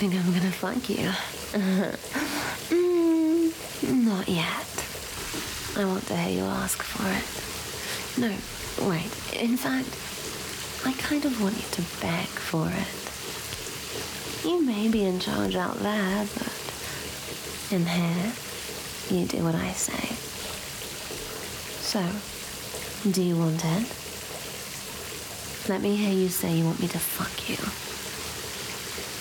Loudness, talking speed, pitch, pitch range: -28 LUFS, 120 wpm, 200 Hz, 180-235 Hz